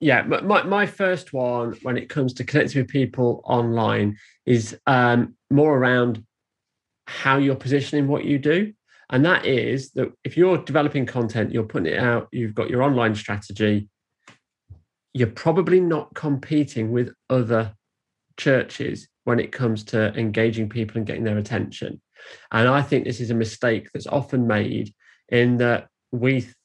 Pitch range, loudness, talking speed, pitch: 115-140 Hz, -22 LUFS, 160 wpm, 125 Hz